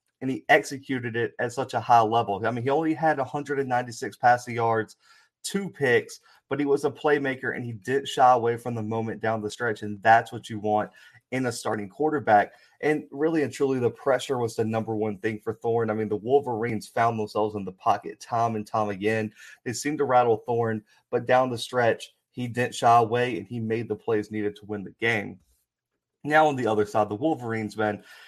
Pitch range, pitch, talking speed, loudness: 110-135 Hz, 115 Hz, 215 wpm, -25 LUFS